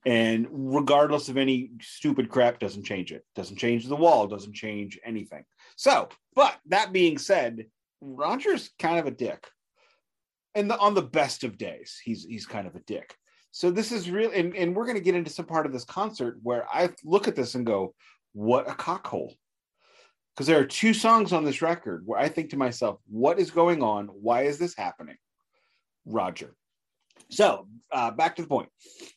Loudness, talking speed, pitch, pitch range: -26 LUFS, 190 wpm, 140 Hz, 115-180 Hz